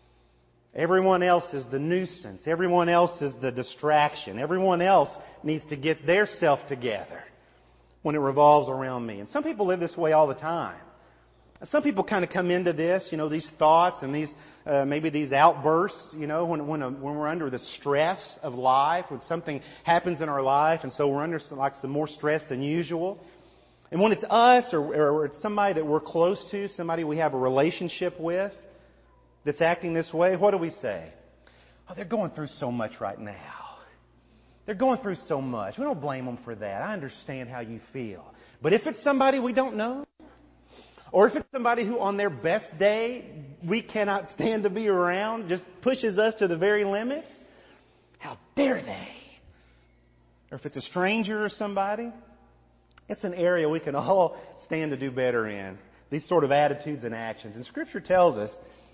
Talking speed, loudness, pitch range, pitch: 190 wpm, -26 LUFS, 135-195 Hz, 160 Hz